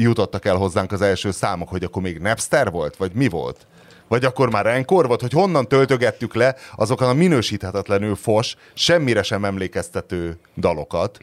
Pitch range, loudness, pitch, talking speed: 95-130 Hz, -20 LUFS, 110 Hz, 165 wpm